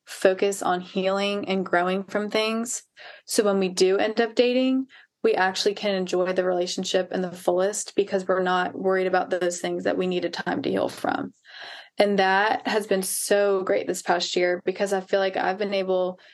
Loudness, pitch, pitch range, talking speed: -24 LUFS, 190 Hz, 185-205 Hz, 200 wpm